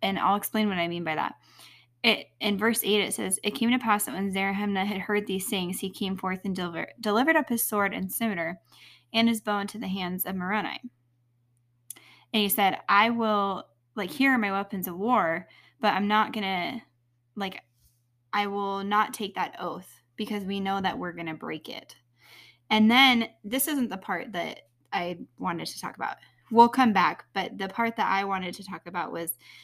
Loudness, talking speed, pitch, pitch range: -27 LUFS, 200 wpm, 195 Hz, 170-215 Hz